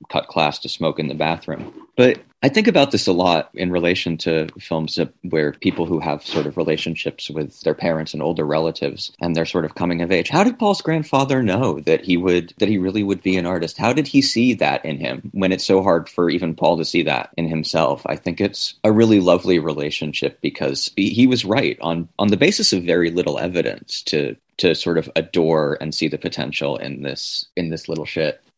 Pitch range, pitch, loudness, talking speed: 80-100 Hz, 85 Hz, -19 LUFS, 225 wpm